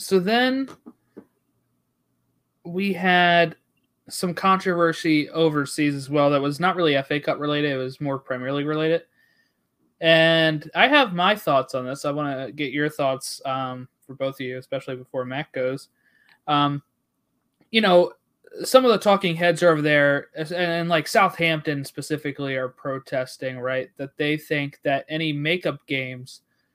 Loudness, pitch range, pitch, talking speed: -22 LUFS, 135-170 Hz, 150 Hz, 155 wpm